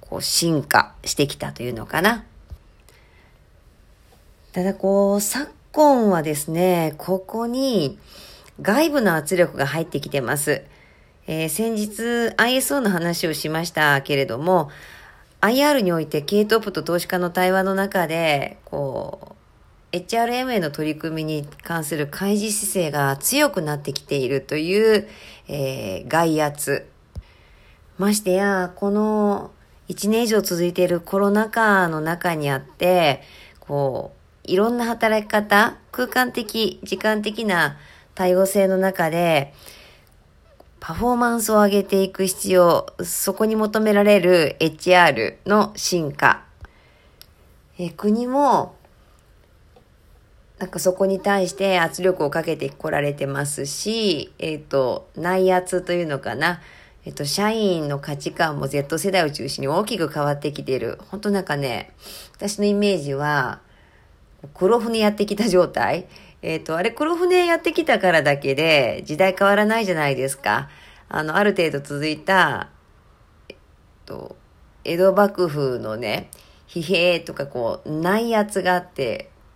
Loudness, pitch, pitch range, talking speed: -20 LUFS, 180 Hz, 150-205 Hz, 250 characters per minute